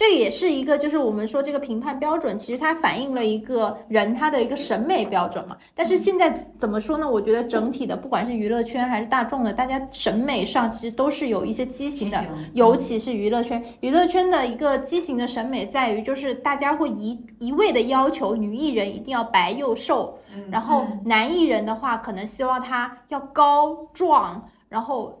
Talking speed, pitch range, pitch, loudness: 310 characters per minute, 225-285 Hz, 250 Hz, -22 LUFS